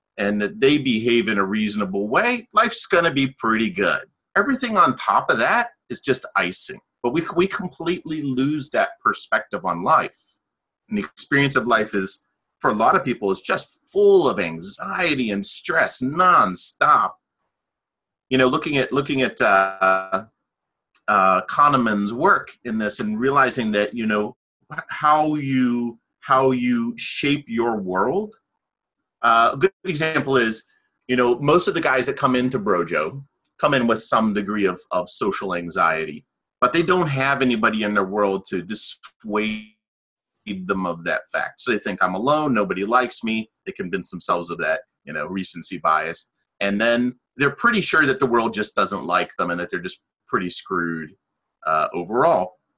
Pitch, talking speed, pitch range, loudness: 125 Hz, 170 wpm, 105-150 Hz, -20 LUFS